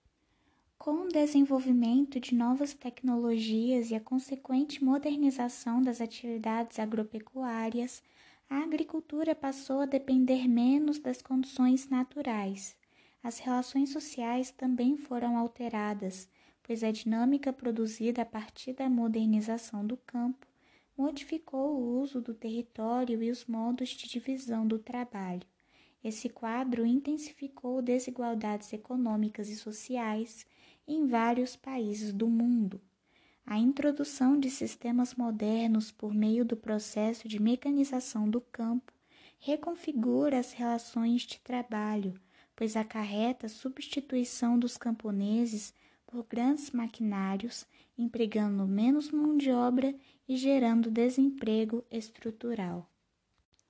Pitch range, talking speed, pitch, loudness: 225-260 Hz, 110 wpm, 240 Hz, -32 LUFS